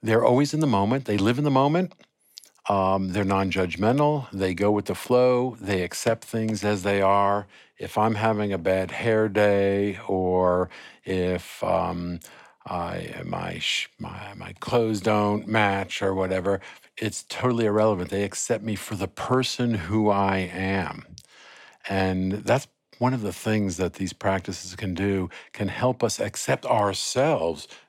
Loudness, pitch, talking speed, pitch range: -25 LUFS, 100 Hz, 155 wpm, 95-110 Hz